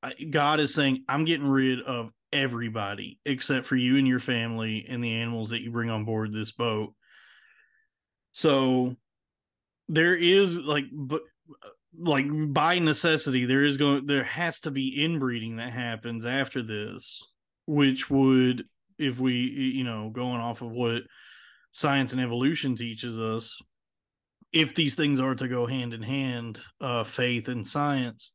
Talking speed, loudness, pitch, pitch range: 150 wpm, -27 LUFS, 130 Hz, 120-145 Hz